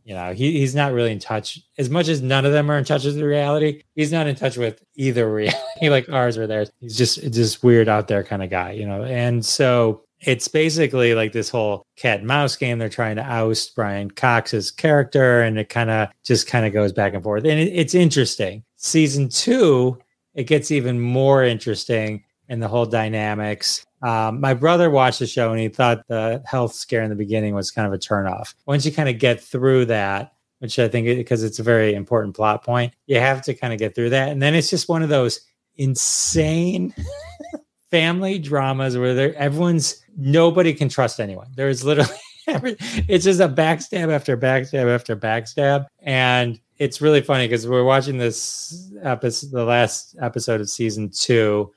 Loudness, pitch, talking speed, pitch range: -19 LUFS, 125 Hz, 205 wpm, 110-145 Hz